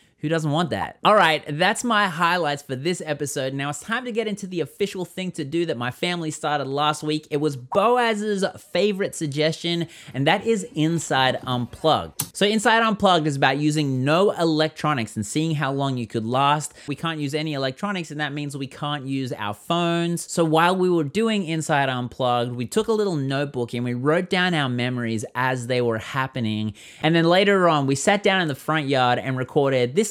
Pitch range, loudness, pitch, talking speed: 135-175 Hz, -22 LUFS, 155 Hz, 205 wpm